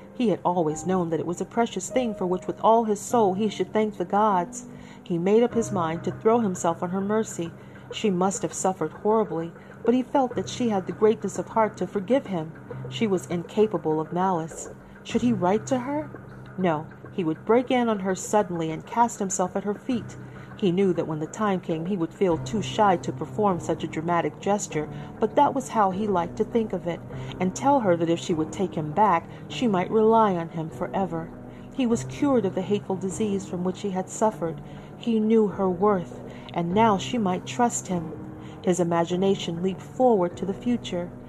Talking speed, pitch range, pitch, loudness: 215 wpm, 170-220 Hz, 190 Hz, -25 LUFS